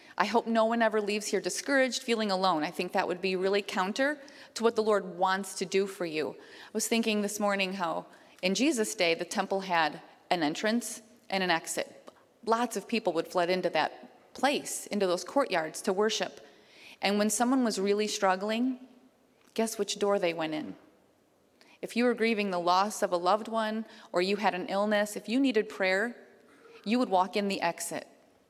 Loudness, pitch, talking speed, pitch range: -29 LUFS, 205 Hz, 195 wpm, 185-225 Hz